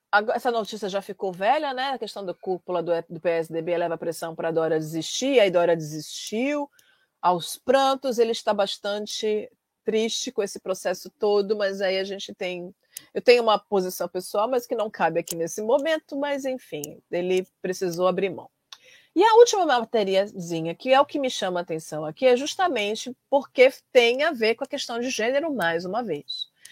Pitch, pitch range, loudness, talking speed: 205 Hz, 175-255 Hz, -24 LUFS, 185 wpm